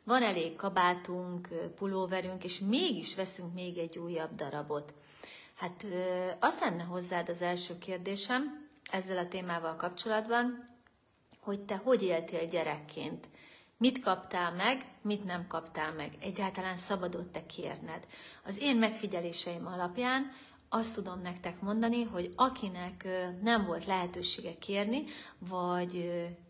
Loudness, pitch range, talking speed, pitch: -35 LUFS, 175-205 Hz, 120 wpm, 180 Hz